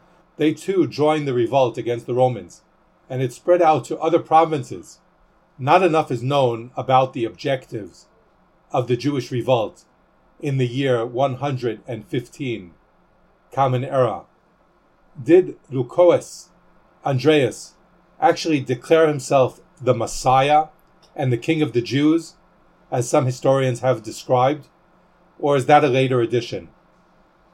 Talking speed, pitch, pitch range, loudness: 125 wpm, 135 Hz, 125-155 Hz, -20 LUFS